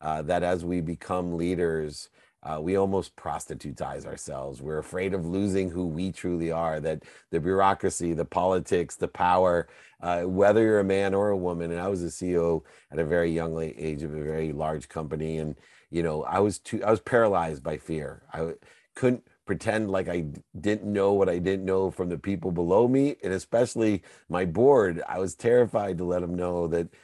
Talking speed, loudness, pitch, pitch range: 195 wpm, -27 LUFS, 90 Hz, 80-95 Hz